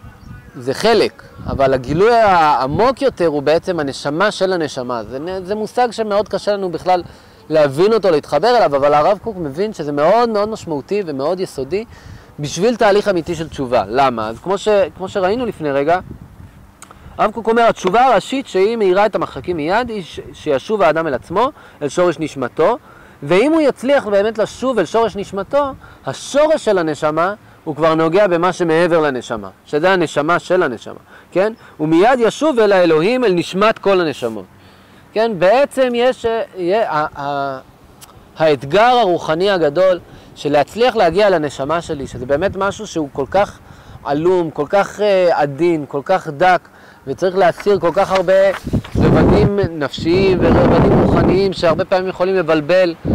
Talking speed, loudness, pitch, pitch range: 150 wpm, -15 LUFS, 180 Hz, 150-205 Hz